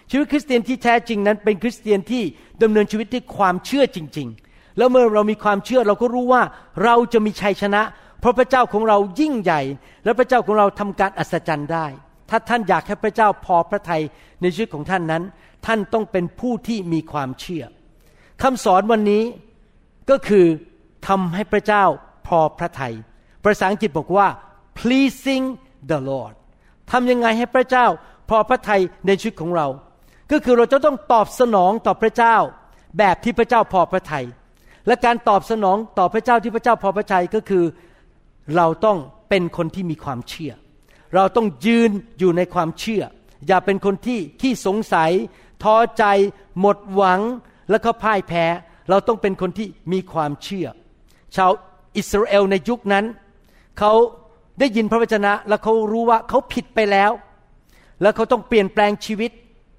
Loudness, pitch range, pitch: -19 LUFS, 180-230 Hz, 205 Hz